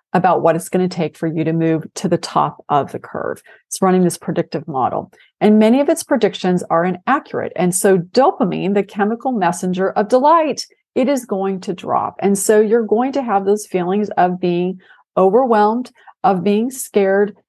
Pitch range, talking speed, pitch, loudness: 180-230 Hz, 190 wpm, 200 Hz, -17 LUFS